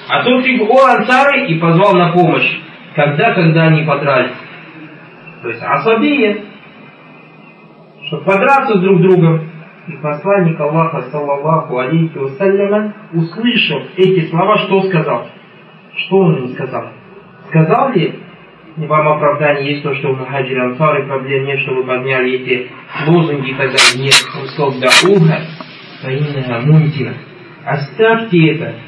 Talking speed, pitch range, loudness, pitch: 135 wpm, 140-195 Hz, -12 LUFS, 165 Hz